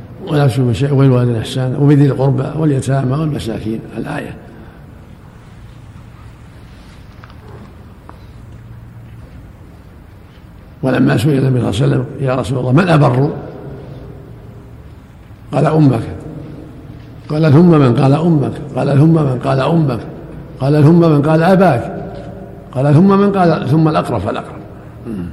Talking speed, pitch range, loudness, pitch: 110 wpm, 115-150 Hz, -13 LUFS, 130 Hz